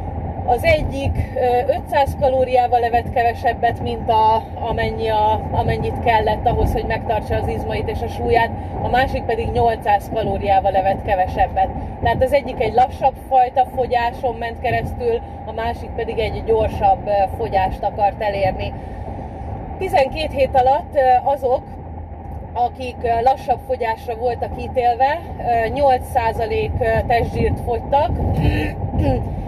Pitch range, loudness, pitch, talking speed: 195-260 Hz, -19 LUFS, 235 Hz, 115 wpm